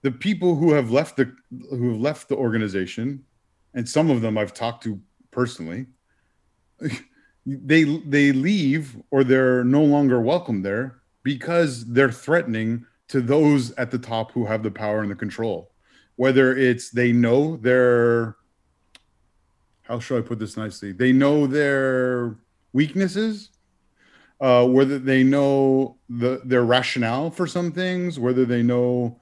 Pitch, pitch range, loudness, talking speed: 125 Hz, 115-140 Hz, -21 LUFS, 145 wpm